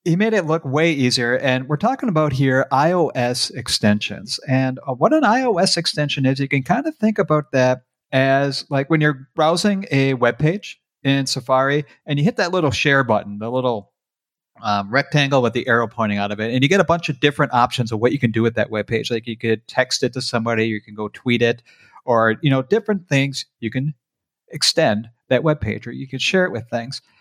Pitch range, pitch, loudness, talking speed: 120-155 Hz, 135 Hz, -19 LUFS, 225 wpm